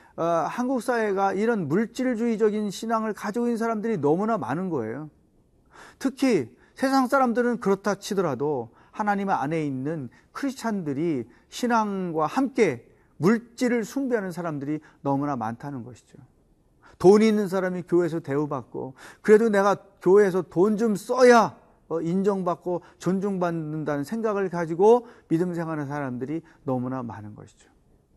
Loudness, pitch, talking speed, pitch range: -24 LUFS, 195 Hz, 315 characters per minute, 155-225 Hz